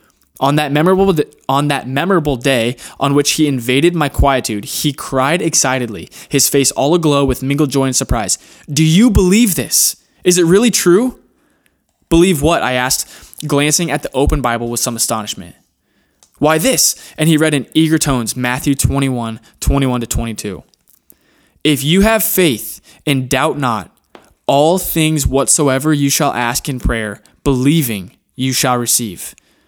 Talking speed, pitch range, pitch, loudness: 160 wpm, 125-160 Hz, 140 Hz, -14 LUFS